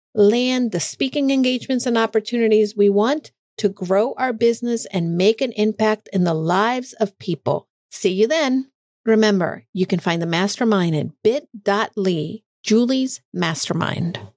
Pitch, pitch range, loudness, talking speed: 215 Hz, 185-240 Hz, -20 LUFS, 140 wpm